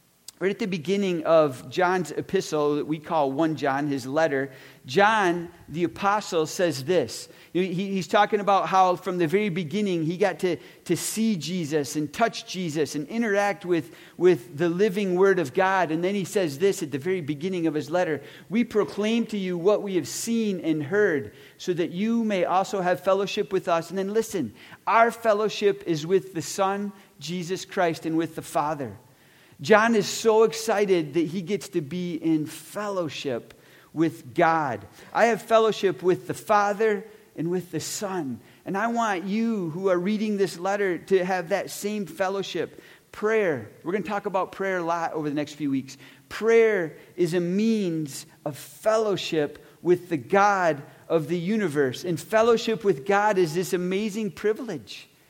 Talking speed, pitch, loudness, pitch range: 175 wpm, 185 Hz, -25 LUFS, 160-205 Hz